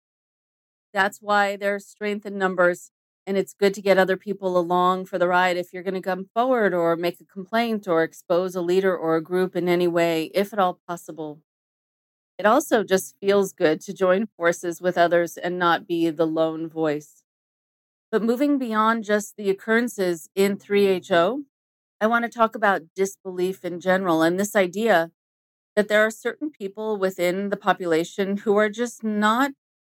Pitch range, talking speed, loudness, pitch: 175-210 Hz, 175 wpm, -23 LUFS, 190 Hz